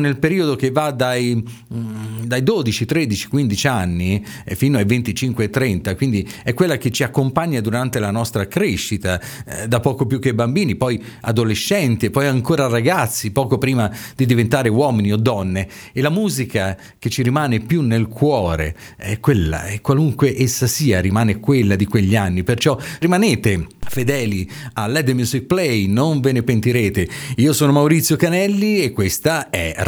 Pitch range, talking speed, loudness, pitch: 105-140 Hz, 165 wpm, -18 LUFS, 120 Hz